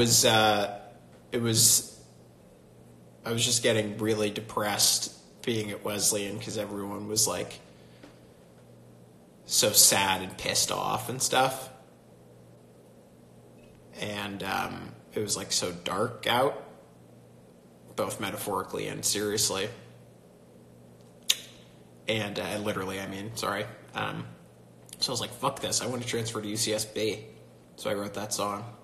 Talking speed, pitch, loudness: 125 wpm, 95 Hz, -27 LUFS